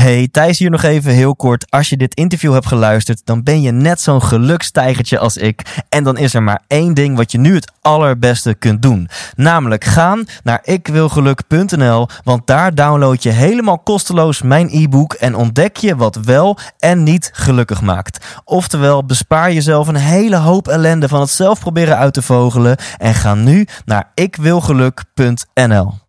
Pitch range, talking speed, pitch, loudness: 120-160 Hz, 175 wpm, 140 Hz, -12 LUFS